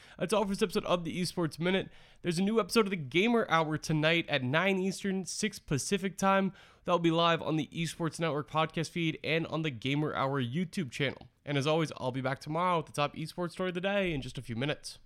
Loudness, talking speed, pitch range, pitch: -31 LUFS, 245 wpm, 150-185 Hz, 165 Hz